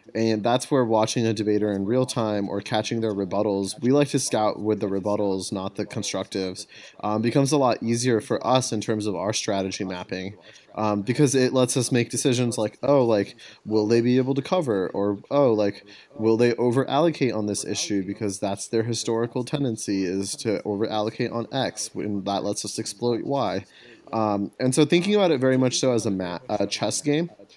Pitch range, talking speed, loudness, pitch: 100-125 Hz, 200 wpm, -24 LUFS, 110 Hz